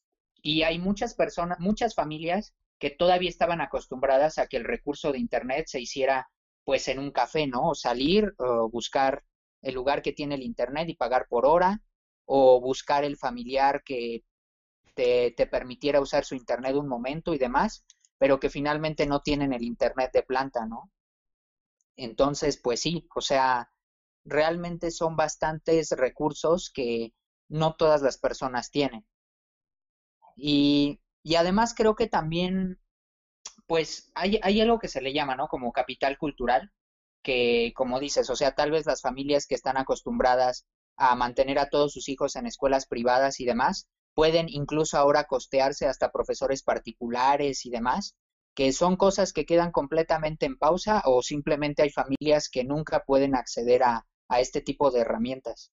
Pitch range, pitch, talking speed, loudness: 130-165 Hz, 145 Hz, 160 wpm, -26 LUFS